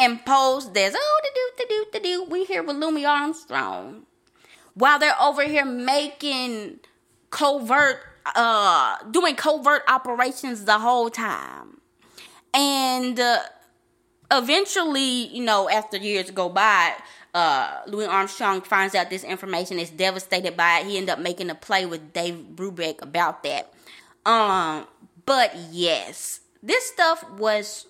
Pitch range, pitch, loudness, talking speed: 195-295 Hz, 250 Hz, -22 LUFS, 135 wpm